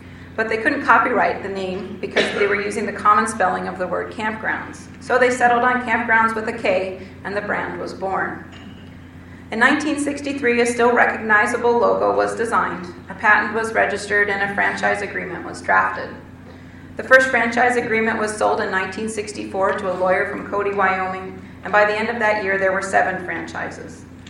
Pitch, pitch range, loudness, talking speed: 210 Hz, 190-230 Hz, -19 LUFS, 180 wpm